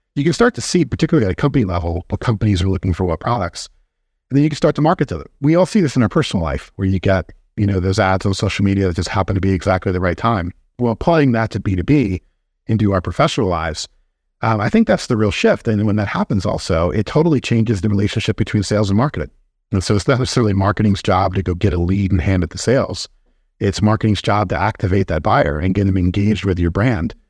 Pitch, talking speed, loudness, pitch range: 100 Hz, 250 wpm, -17 LUFS, 95-115 Hz